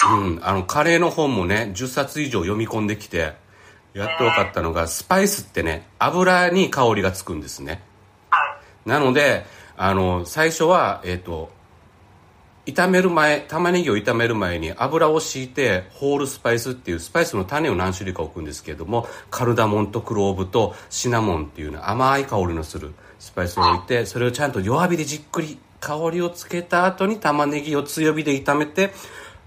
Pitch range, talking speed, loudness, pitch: 95-150 Hz, 355 characters per minute, -21 LUFS, 115 Hz